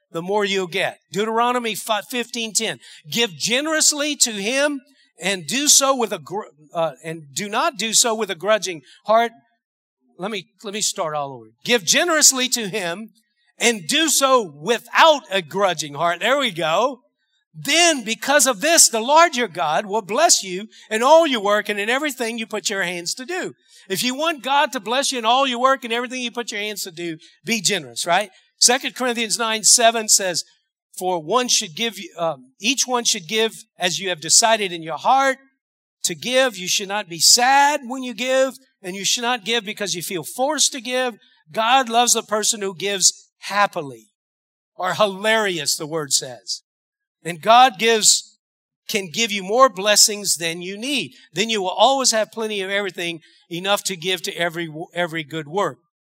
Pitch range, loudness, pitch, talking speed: 185-250 Hz, -18 LUFS, 220 Hz, 190 wpm